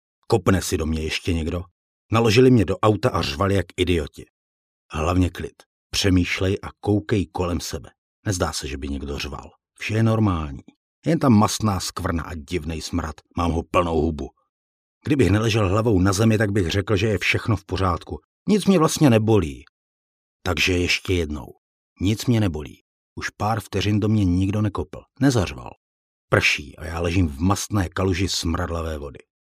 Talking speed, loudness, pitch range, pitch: 165 wpm, -22 LUFS, 80-105 Hz, 90 Hz